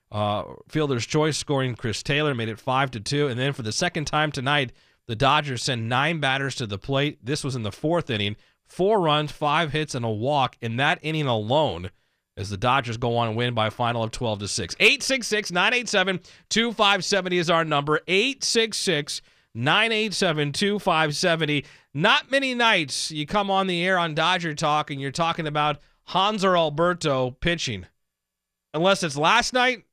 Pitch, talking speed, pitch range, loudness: 150 Hz, 180 wpm, 125-180 Hz, -23 LUFS